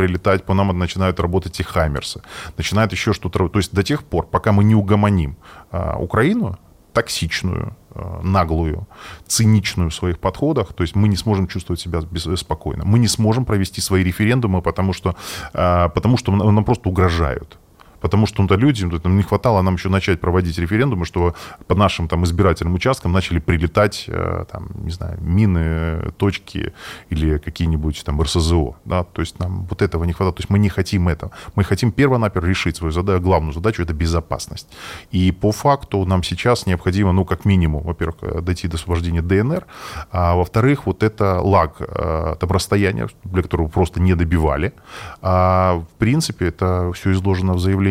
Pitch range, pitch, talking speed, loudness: 85-100 Hz, 95 Hz, 175 wpm, -19 LUFS